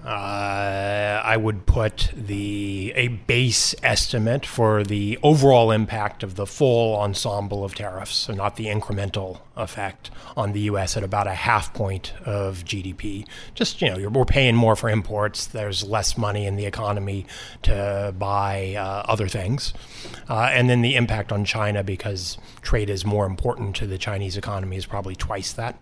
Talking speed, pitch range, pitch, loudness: 170 wpm, 100-110 Hz, 105 Hz, -23 LUFS